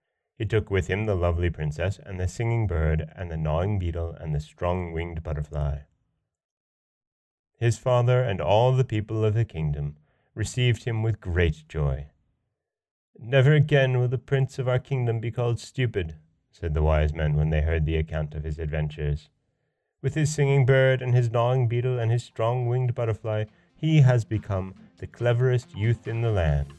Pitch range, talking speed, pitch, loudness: 80-125 Hz, 175 wpm, 105 Hz, -25 LUFS